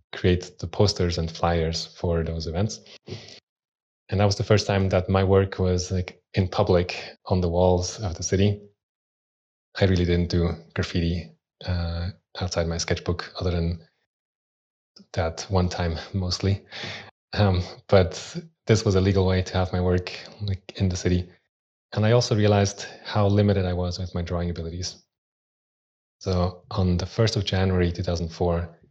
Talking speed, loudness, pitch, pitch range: 165 wpm, -25 LUFS, 90 Hz, 90-100 Hz